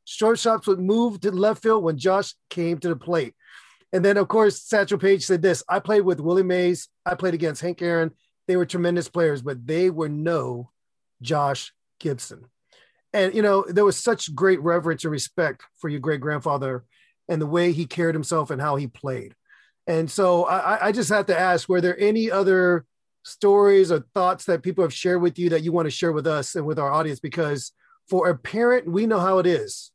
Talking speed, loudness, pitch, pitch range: 210 wpm, -22 LUFS, 175 Hz, 160-195 Hz